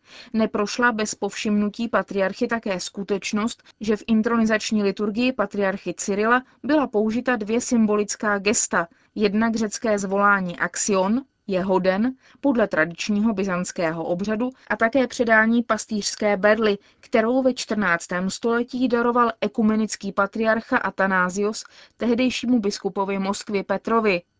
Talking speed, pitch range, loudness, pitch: 110 wpm, 200-235 Hz, -22 LUFS, 215 Hz